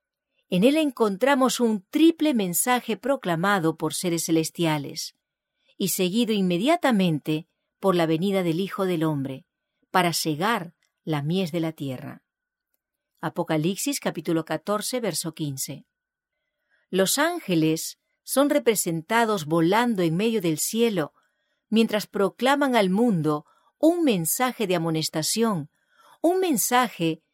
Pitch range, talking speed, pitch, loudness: 165-255 Hz, 110 wpm, 195 Hz, -24 LUFS